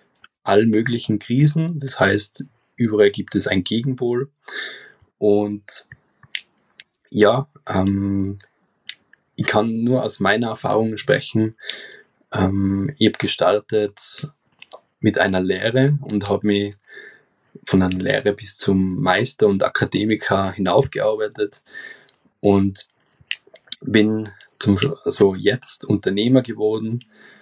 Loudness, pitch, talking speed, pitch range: -20 LUFS, 105 Hz, 100 wpm, 100-125 Hz